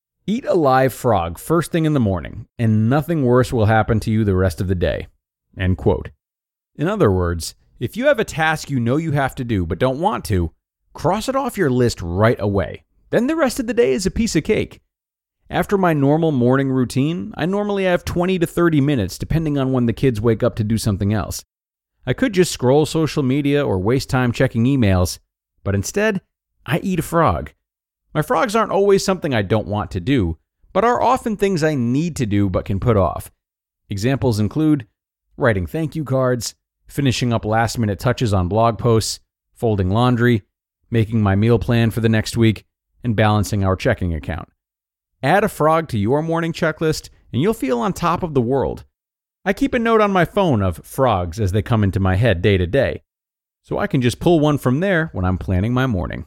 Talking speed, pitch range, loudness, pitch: 210 wpm, 100-160 Hz, -19 LUFS, 125 Hz